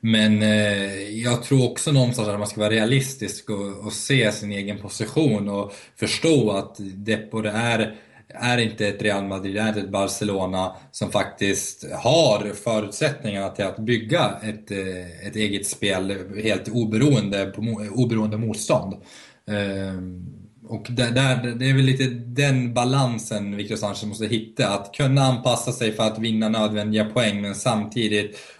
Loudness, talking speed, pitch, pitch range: -23 LUFS, 145 wpm, 110 Hz, 100-120 Hz